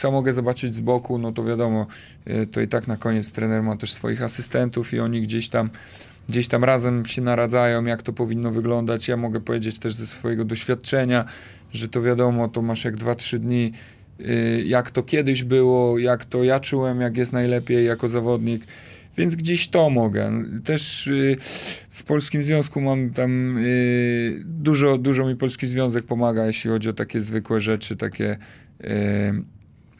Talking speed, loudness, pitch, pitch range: 165 wpm, -22 LUFS, 120 Hz, 115-125 Hz